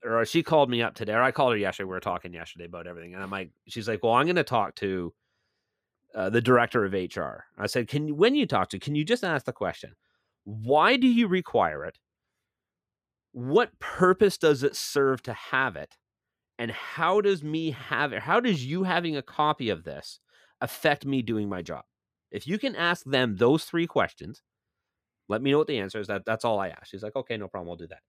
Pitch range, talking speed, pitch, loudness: 100-155 Hz, 230 wpm, 120 Hz, -26 LUFS